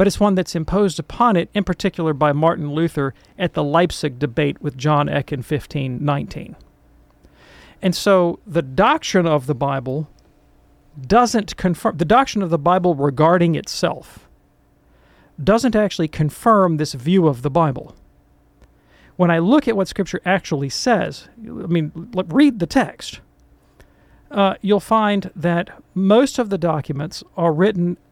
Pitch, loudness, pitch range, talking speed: 170 Hz, -18 LUFS, 150-195 Hz, 145 wpm